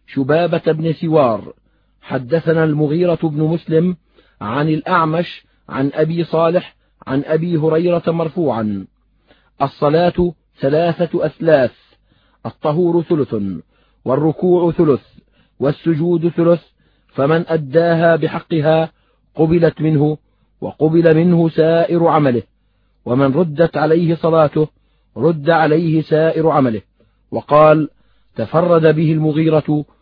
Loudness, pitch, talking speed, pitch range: -15 LUFS, 160 Hz, 90 wpm, 150-165 Hz